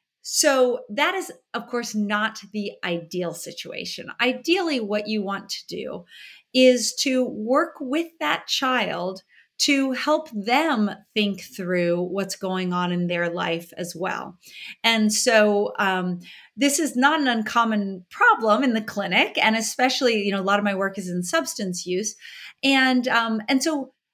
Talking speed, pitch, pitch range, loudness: 155 wpm, 220 Hz, 195-265 Hz, -22 LUFS